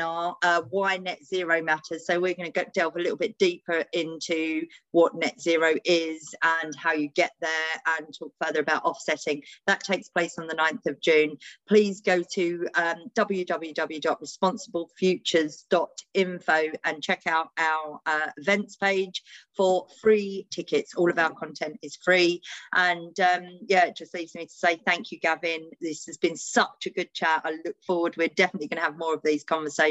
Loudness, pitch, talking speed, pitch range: -26 LUFS, 170 Hz, 180 wpm, 160-185 Hz